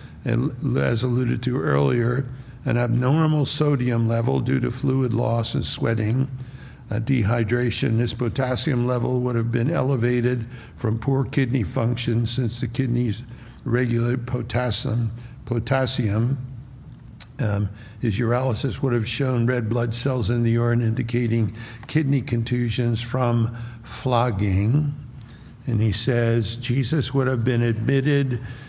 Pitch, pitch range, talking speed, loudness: 120 Hz, 115-130 Hz, 125 wpm, -23 LUFS